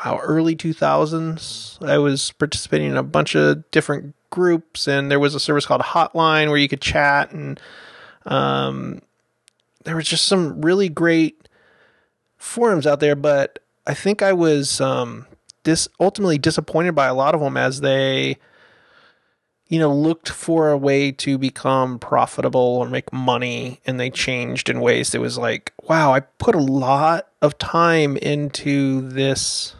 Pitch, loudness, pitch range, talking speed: 140 Hz, -19 LUFS, 125-160 Hz, 160 wpm